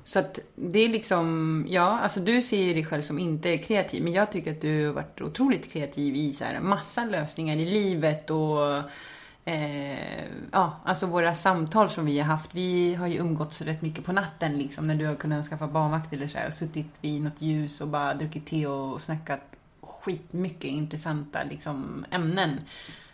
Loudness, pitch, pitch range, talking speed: -28 LUFS, 160 Hz, 150-180 Hz, 185 wpm